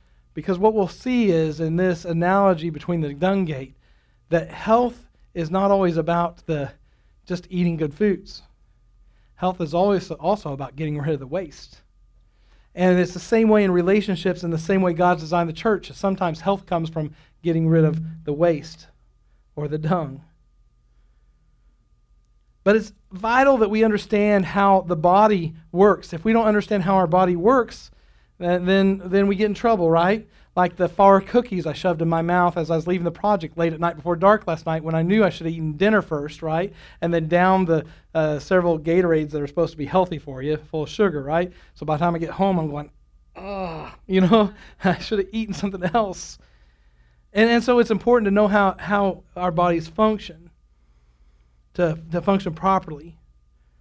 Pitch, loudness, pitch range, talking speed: 175 Hz, -21 LUFS, 155-195 Hz, 190 wpm